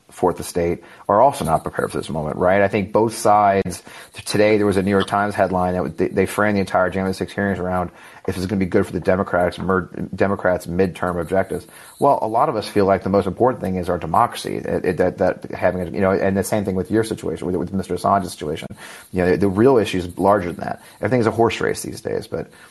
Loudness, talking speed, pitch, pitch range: -20 LUFS, 250 wpm, 95 Hz, 90-100 Hz